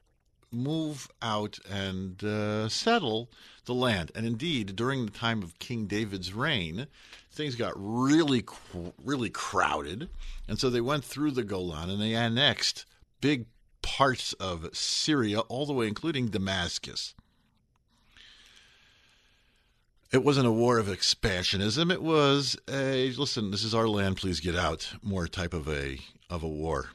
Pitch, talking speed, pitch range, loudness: 115 Hz, 145 wpm, 95-130 Hz, -29 LUFS